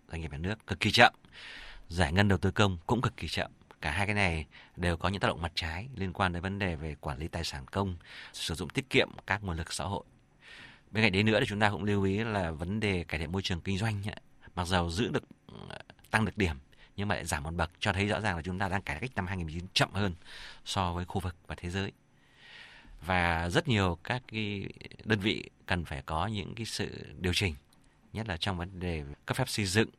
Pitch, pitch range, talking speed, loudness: 95 Hz, 85-105 Hz, 250 wpm, -31 LUFS